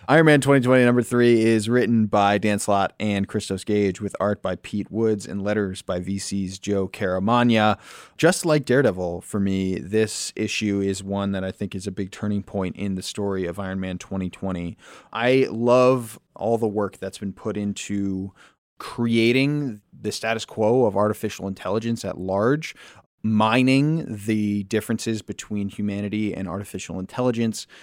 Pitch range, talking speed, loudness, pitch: 95-115 Hz, 160 wpm, -23 LUFS, 105 Hz